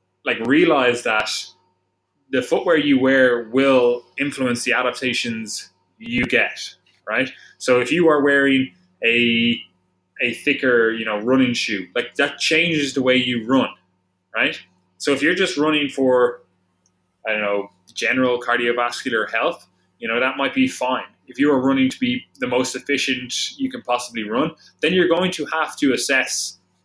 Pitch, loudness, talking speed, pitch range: 125 Hz, -19 LUFS, 160 wpm, 105-140 Hz